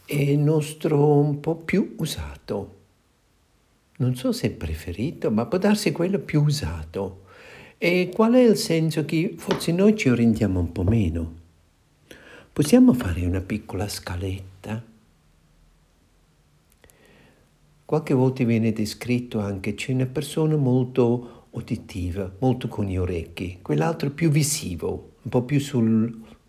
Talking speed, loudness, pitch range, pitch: 130 wpm, -23 LUFS, 95-150 Hz, 120 Hz